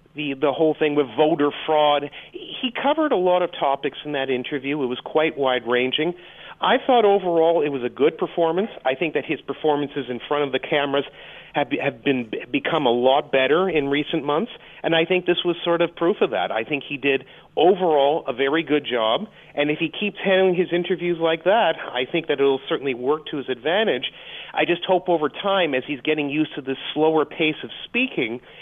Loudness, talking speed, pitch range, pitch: -21 LUFS, 215 wpm, 140-175 Hz, 155 Hz